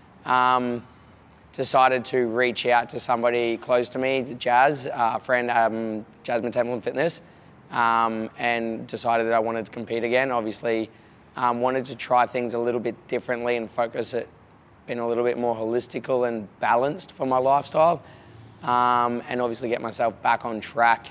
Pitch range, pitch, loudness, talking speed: 115-125 Hz, 120 Hz, -24 LUFS, 170 wpm